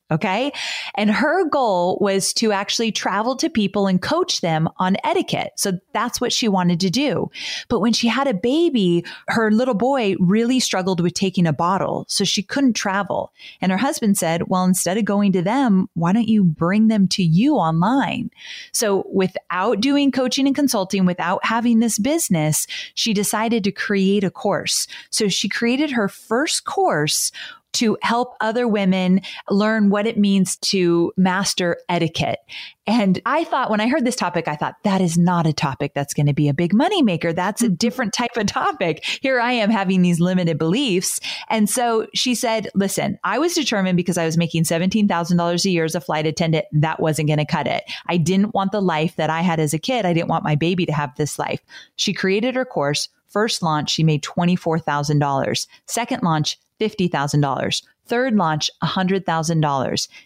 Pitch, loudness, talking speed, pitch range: 195 Hz, -19 LUFS, 185 wpm, 170-235 Hz